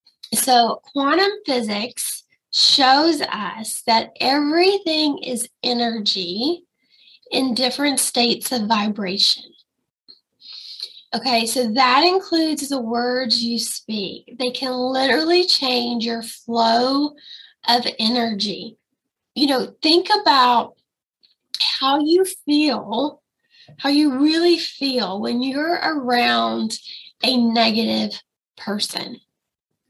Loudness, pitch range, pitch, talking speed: -19 LUFS, 230-295 Hz, 255 Hz, 95 wpm